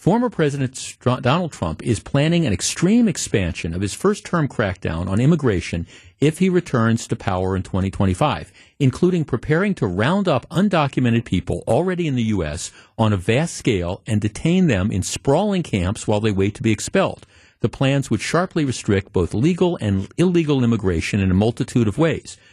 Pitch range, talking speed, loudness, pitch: 100-155 Hz, 175 wpm, -20 LUFS, 120 Hz